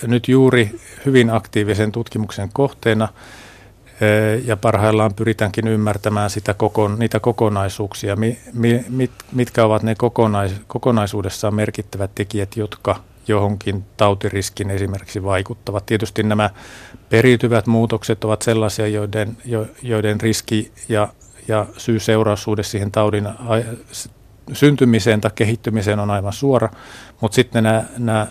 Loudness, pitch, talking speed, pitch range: -18 LUFS, 110 Hz, 110 wpm, 105-115 Hz